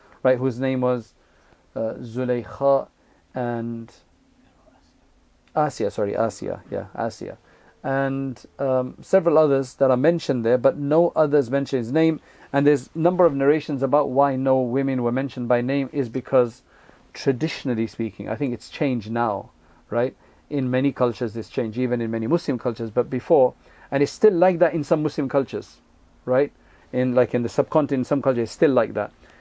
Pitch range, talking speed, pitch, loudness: 120-140 Hz, 170 wpm, 130 Hz, -22 LUFS